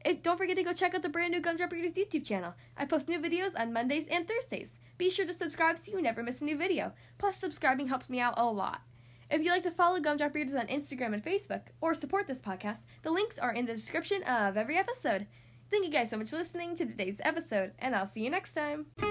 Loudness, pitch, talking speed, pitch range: -33 LUFS, 315 Hz, 250 wpm, 240-350 Hz